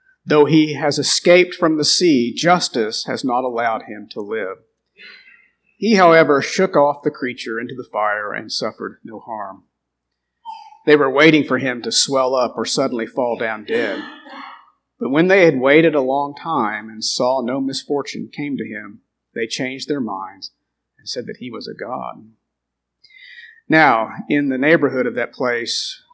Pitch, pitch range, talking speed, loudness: 150 Hz, 135-215 Hz, 170 wpm, -17 LUFS